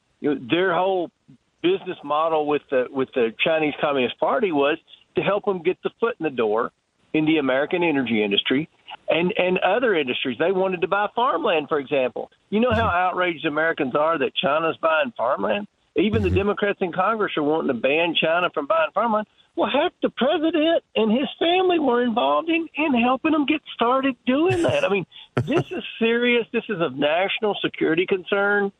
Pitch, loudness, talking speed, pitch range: 200 Hz, -22 LUFS, 185 wpm, 160-260 Hz